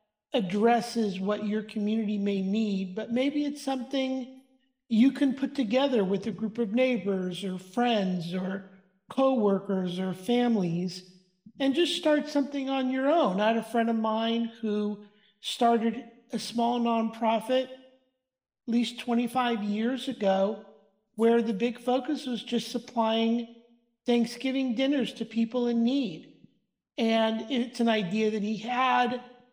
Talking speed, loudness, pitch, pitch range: 140 wpm, -28 LUFS, 235 Hz, 210-255 Hz